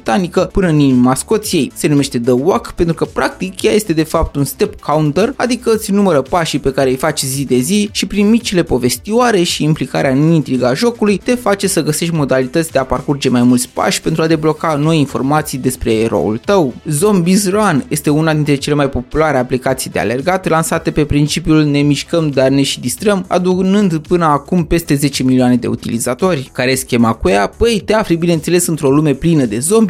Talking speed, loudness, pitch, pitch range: 200 wpm, -13 LUFS, 155 Hz, 135-185 Hz